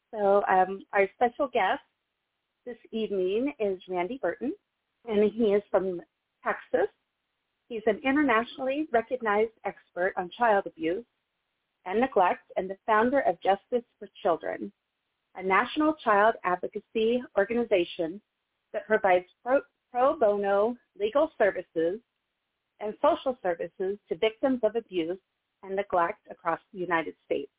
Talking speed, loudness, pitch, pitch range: 125 wpm, -28 LUFS, 210 Hz, 185-245 Hz